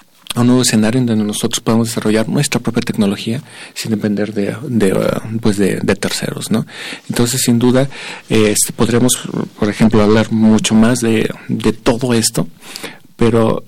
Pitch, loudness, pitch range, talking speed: 115 Hz, -14 LUFS, 110-120 Hz, 160 wpm